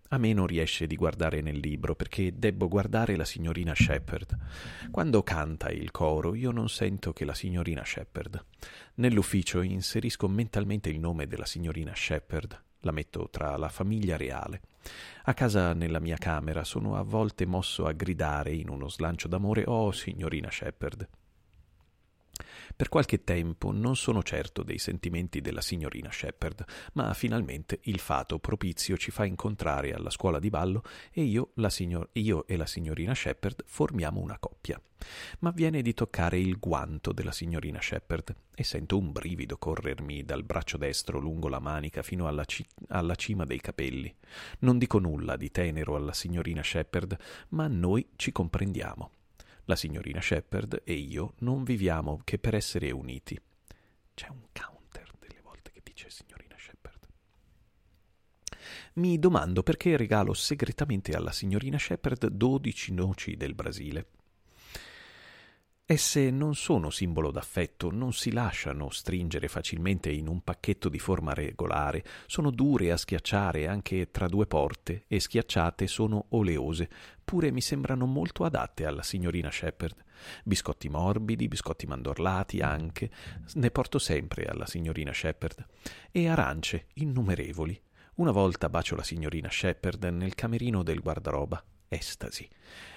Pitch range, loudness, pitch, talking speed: 80-110 Hz, -31 LUFS, 90 Hz, 145 wpm